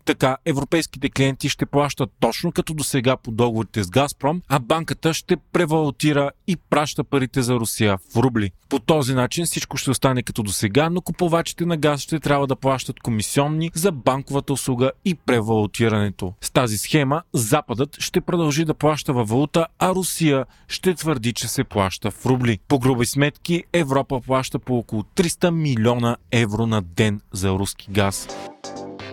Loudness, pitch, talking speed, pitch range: -21 LUFS, 135 Hz, 165 wpm, 120-155 Hz